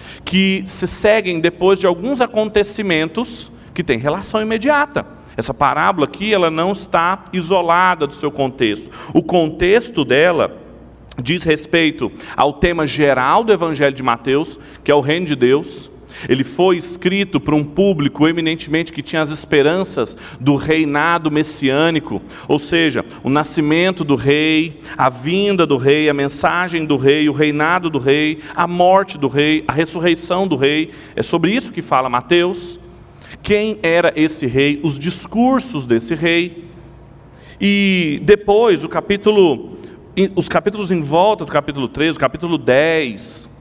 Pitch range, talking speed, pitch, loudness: 145-185 Hz, 145 wpm, 165 Hz, -16 LUFS